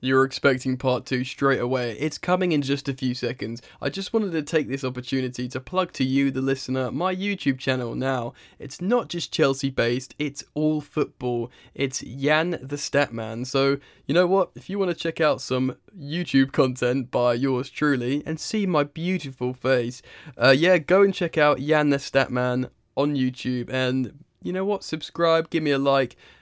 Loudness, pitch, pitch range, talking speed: -24 LUFS, 140 Hz, 130-160 Hz, 190 wpm